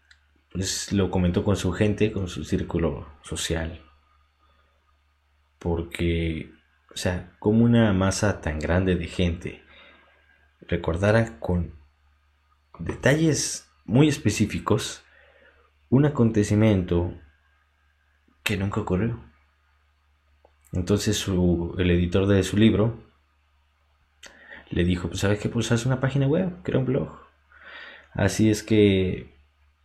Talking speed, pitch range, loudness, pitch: 105 wpm, 75-105 Hz, -24 LUFS, 90 Hz